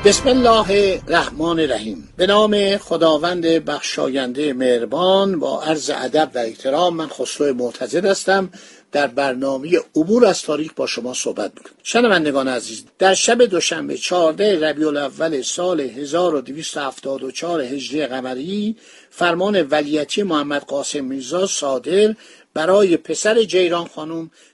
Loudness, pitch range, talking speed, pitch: -18 LUFS, 145-195 Hz, 120 wpm, 165 Hz